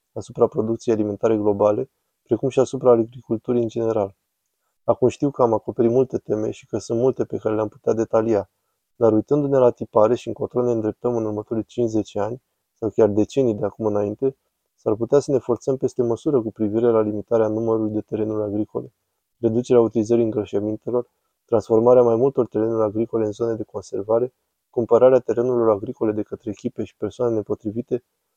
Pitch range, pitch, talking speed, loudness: 110-120 Hz, 115 Hz, 170 wpm, -21 LUFS